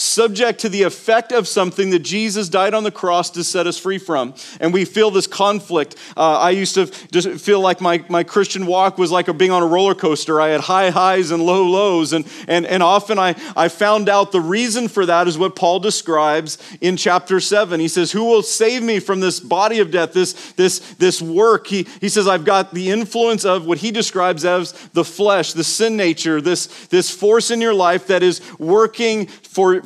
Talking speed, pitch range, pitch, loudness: 220 wpm, 175-205 Hz, 185 Hz, -16 LUFS